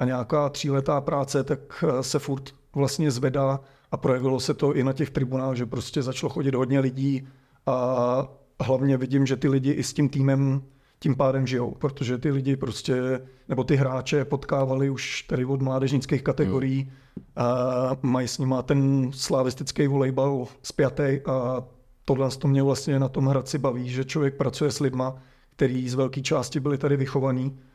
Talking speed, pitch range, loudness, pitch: 170 wpm, 130-140 Hz, -25 LUFS, 135 Hz